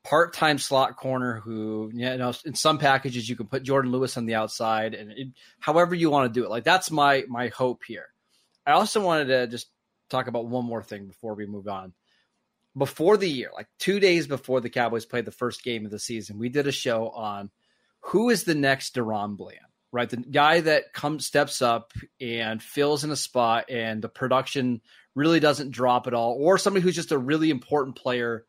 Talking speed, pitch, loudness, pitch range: 210 wpm, 125 Hz, -25 LUFS, 115-145 Hz